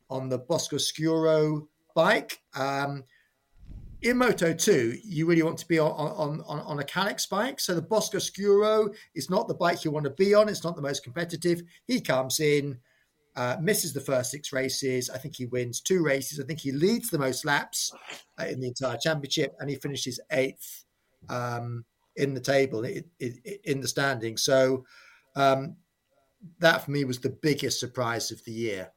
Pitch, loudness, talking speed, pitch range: 145 Hz, -27 LUFS, 190 wpm, 130-165 Hz